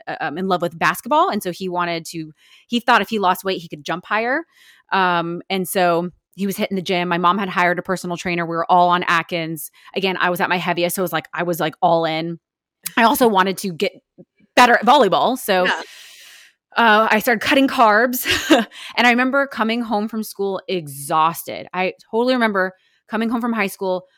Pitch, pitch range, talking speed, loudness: 190 Hz, 175-230 Hz, 210 wpm, -18 LUFS